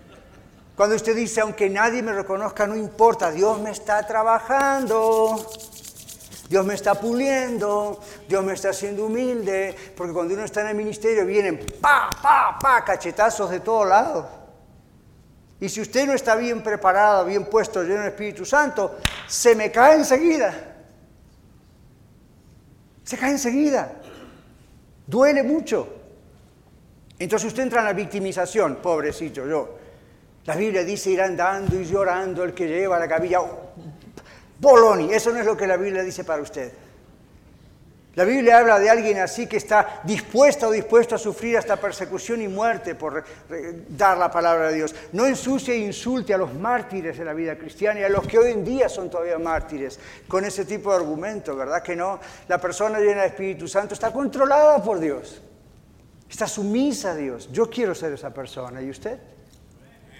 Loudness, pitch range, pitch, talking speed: -21 LUFS, 185-225 Hz, 205 Hz, 165 wpm